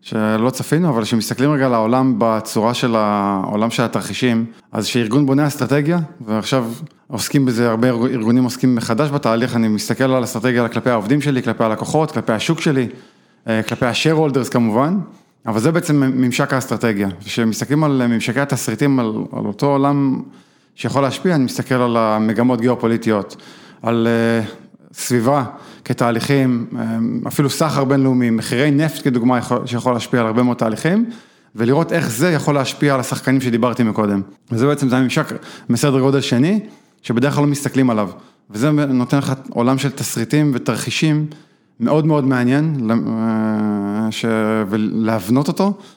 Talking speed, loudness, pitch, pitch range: 145 wpm, -17 LUFS, 125 Hz, 115-140 Hz